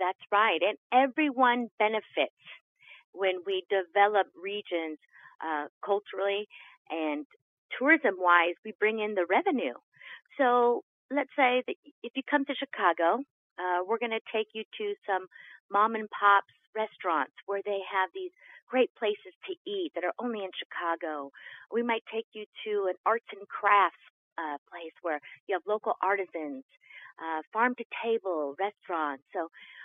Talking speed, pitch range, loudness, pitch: 150 wpm, 180-240 Hz, -29 LUFS, 205 Hz